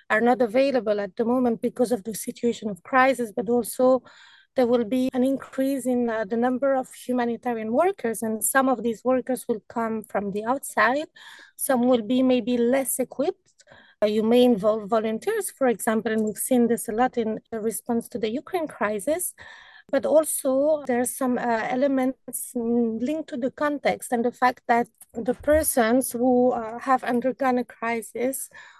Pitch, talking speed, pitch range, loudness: 245 Hz, 175 wpm, 230-265 Hz, -24 LUFS